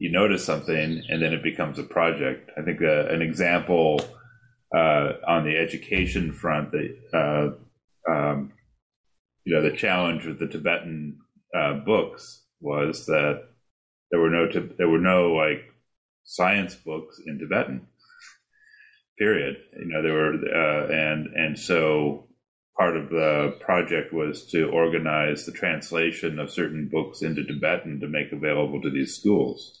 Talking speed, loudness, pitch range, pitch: 150 wpm, -24 LUFS, 75-85 Hz, 80 Hz